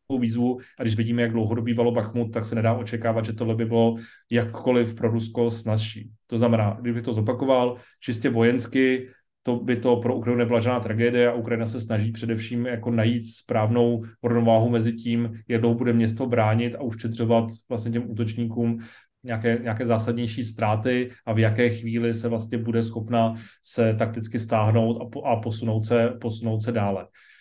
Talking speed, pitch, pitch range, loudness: 170 wpm, 115 Hz, 115-120 Hz, -24 LUFS